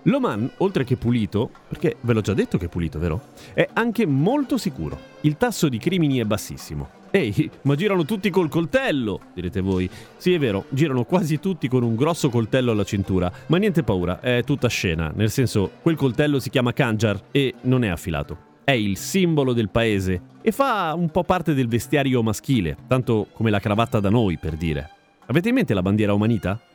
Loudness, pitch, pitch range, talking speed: -22 LUFS, 125 Hz, 100-155 Hz, 195 wpm